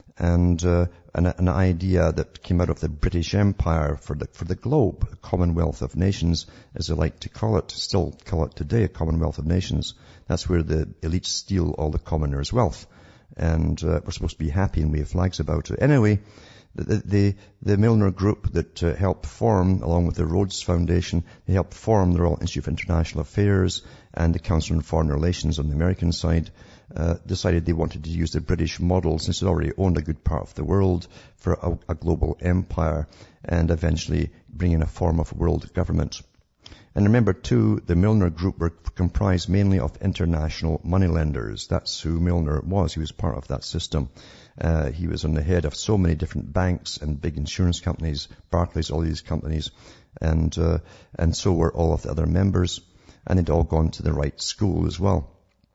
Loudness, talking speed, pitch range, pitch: -24 LUFS, 200 wpm, 80-95 Hz, 85 Hz